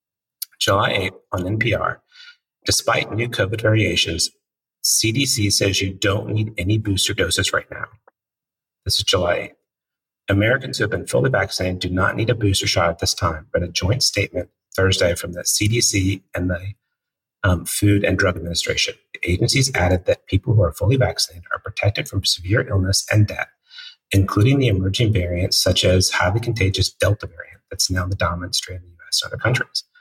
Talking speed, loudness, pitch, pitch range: 180 wpm, -19 LUFS, 100 Hz, 90-110 Hz